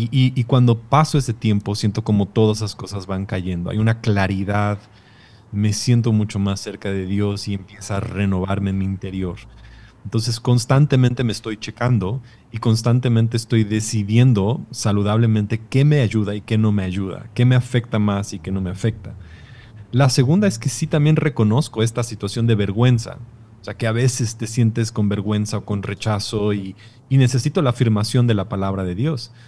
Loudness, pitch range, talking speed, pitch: -19 LUFS, 100-120 Hz, 185 wpm, 110 Hz